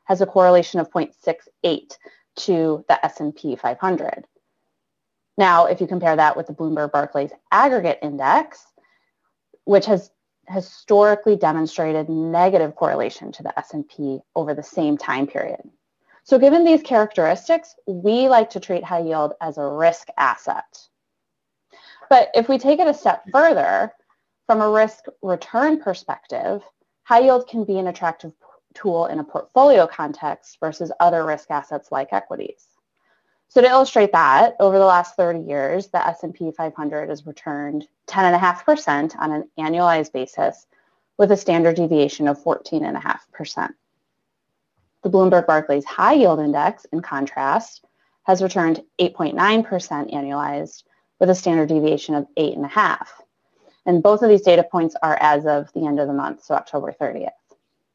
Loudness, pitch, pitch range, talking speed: -19 LUFS, 170 Hz, 150-205 Hz, 140 wpm